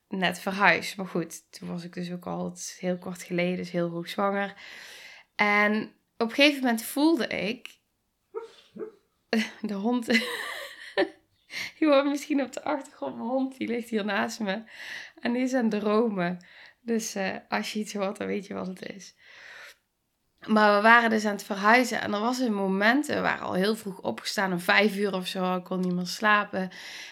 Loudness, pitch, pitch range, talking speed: -26 LUFS, 210 Hz, 185-240 Hz, 190 wpm